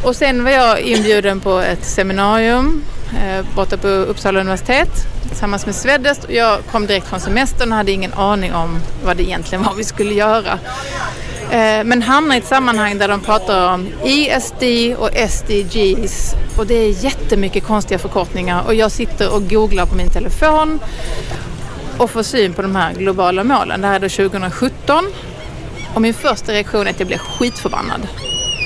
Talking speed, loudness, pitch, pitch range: 175 wpm, -15 LUFS, 210 Hz, 195-235 Hz